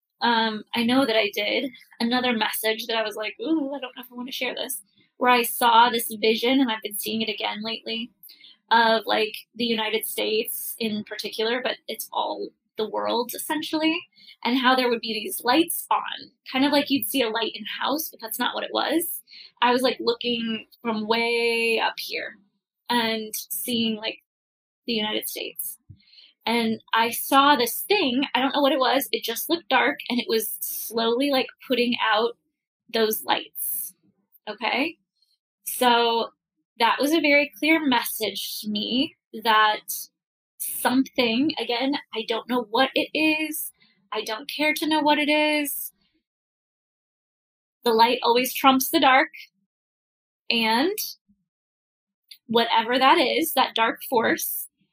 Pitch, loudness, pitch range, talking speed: 235 Hz, -23 LUFS, 220-270 Hz, 160 wpm